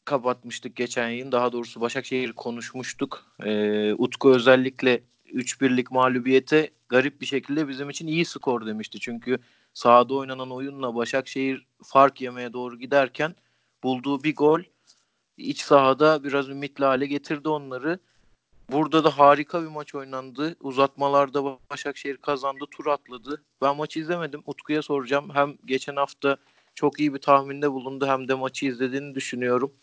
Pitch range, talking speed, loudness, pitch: 125-145 Hz, 135 wpm, -24 LUFS, 135 Hz